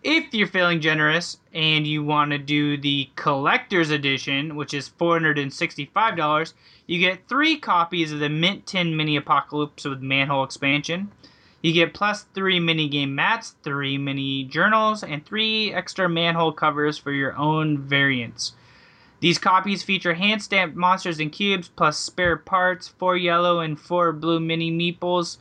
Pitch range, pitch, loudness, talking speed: 150-185 Hz, 165 Hz, -22 LUFS, 155 wpm